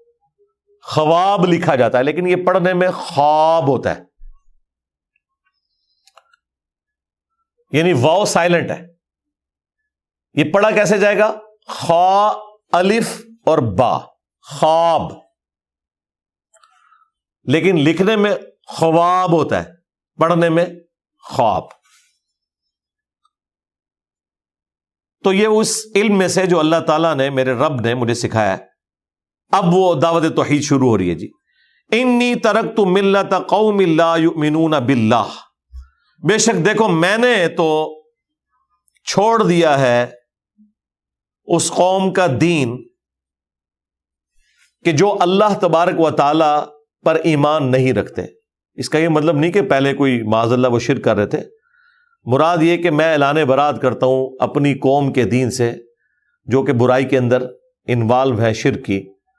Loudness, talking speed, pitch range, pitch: -15 LUFS, 125 wpm, 130-200 Hz, 165 Hz